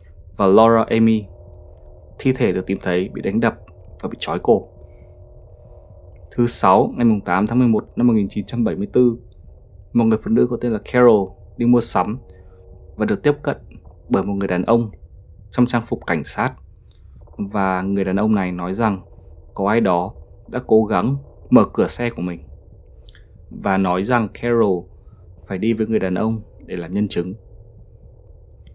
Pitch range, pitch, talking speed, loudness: 90-115 Hz, 100 Hz, 165 wpm, -19 LUFS